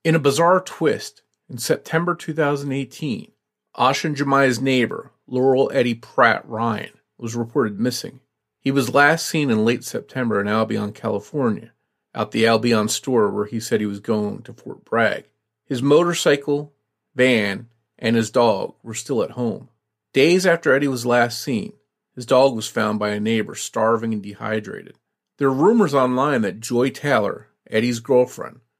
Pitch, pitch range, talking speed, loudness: 125 Hz, 110-145 Hz, 160 wpm, -20 LUFS